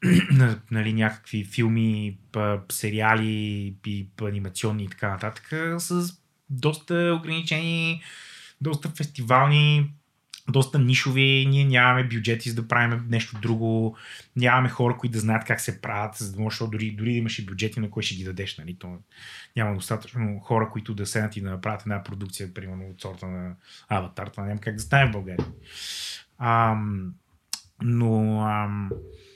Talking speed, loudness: 145 wpm, -25 LUFS